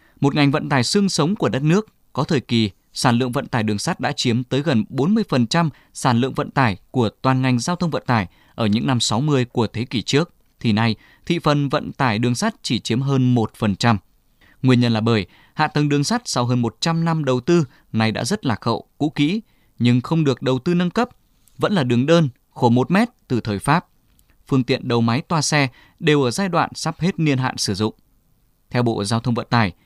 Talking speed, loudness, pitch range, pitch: 230 wpm, -20 LUFS, 115-150 Hz, 130 Hz